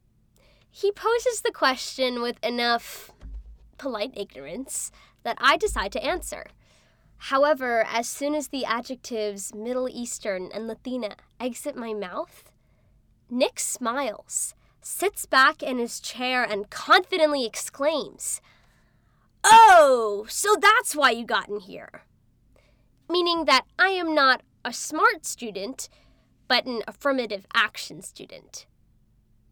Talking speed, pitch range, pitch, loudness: 115 wpm, 215-305 Hz, 250 Hz, -23 LUFS